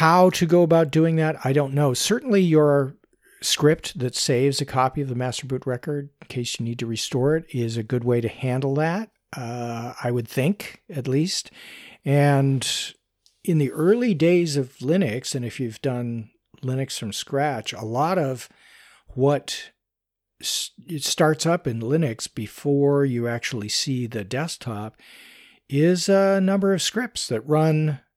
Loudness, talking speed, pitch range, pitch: -23 LUFS, 165 wpm, 125-165 Hz, 140 Hz